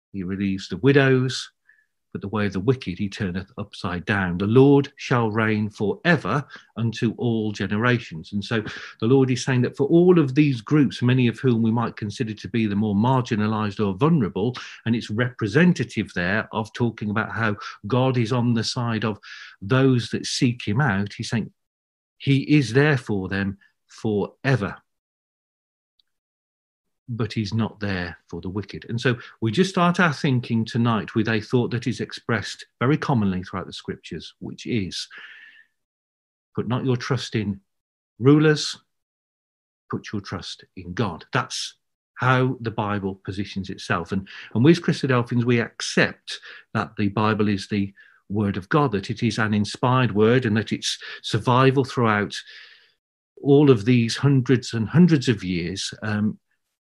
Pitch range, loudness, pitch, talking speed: 100-130 Hz, -22 LUFS, 115 Hz, 160 wpm